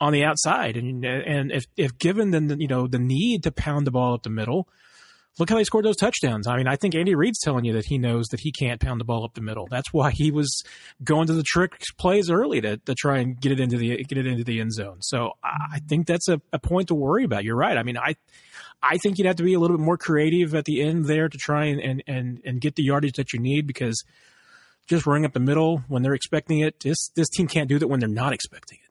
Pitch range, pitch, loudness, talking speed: 125-165 Hz, 145 Hz, -23 LUFS, 280 wpm